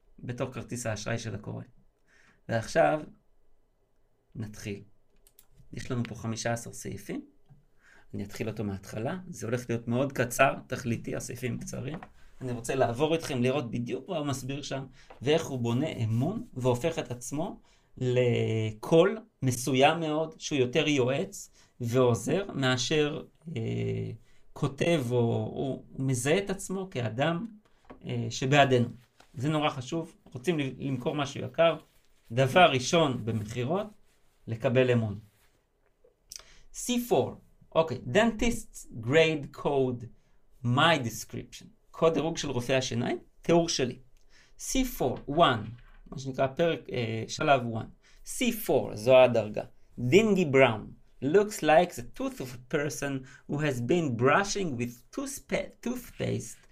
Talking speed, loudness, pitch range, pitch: 120 wpm, -29 LUFS, 120-160 Hz, 130 Hz